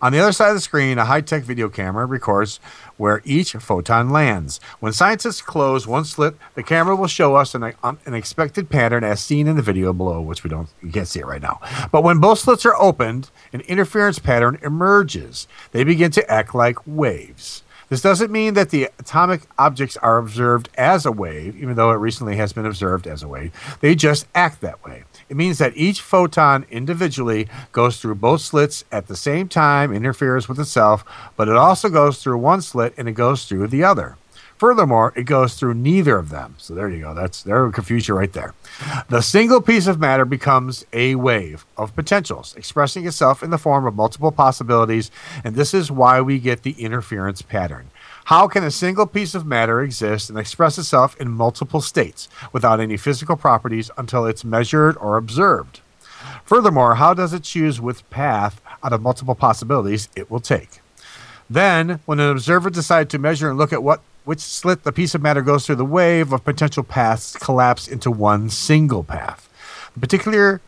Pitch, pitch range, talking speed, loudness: 130 Hz, 115-155 Hz, 195 wpm, -17 LUFS